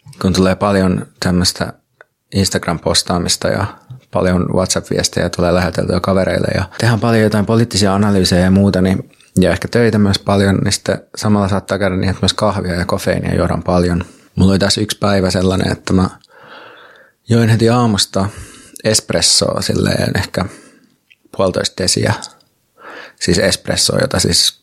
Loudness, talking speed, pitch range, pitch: -14 LUFS, 140 wpm, 90-105 Hz, 95 Hz